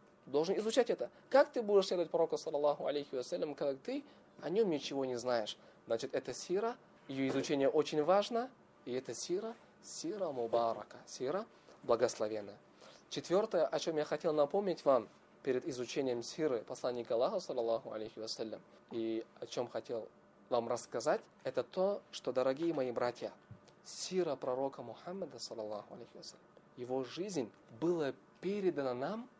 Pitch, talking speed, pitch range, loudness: 145 Hz, 140 wpm, 125-185 Hz, -37 LUFS